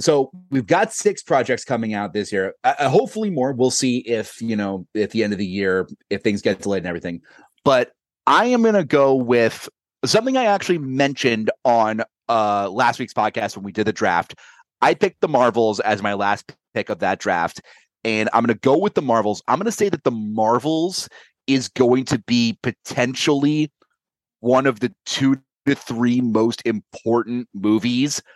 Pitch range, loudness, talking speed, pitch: 110-140 Hz, -20 LUFS, 190 wpm, 120 Hz